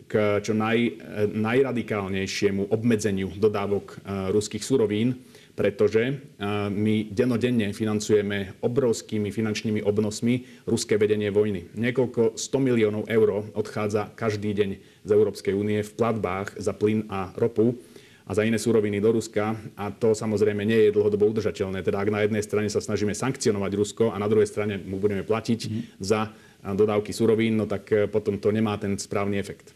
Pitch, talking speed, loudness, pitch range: 105 Hz, 150 wpm, -25 LUFS, 105-115 Hz